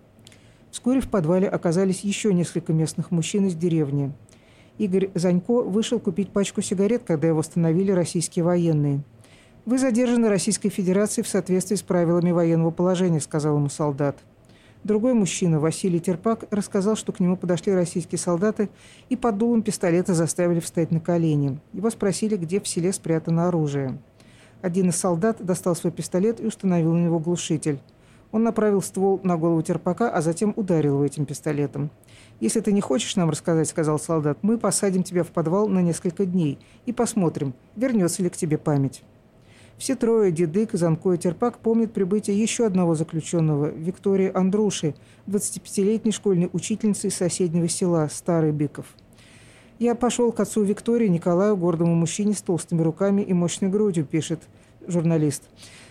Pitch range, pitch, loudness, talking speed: 160-205 Hz, 180 Hz, -23 LUFS, 155 wpm